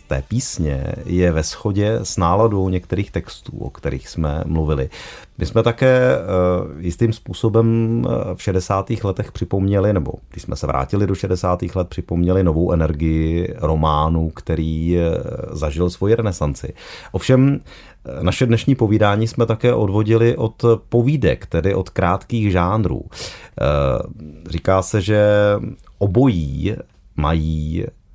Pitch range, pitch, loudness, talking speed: 80-110 Hz, 95 Hz, -19 LUFS, 115 wpm